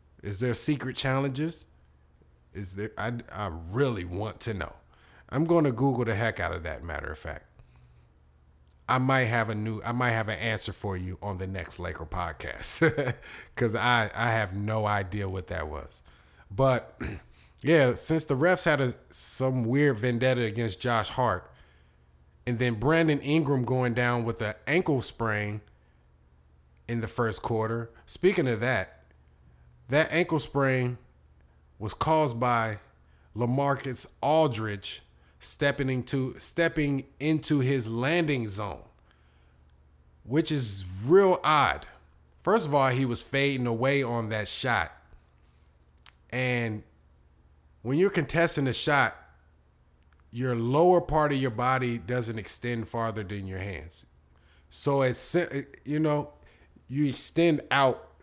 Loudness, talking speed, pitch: -27 LUFS, 140 wpm, 115 Hz